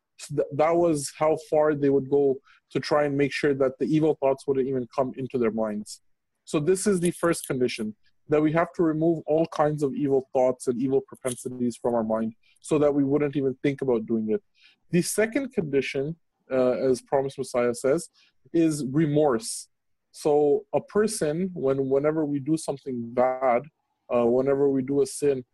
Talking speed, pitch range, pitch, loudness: 185 wpm, 130-155 Hz, 140 Hz, -25 LUFS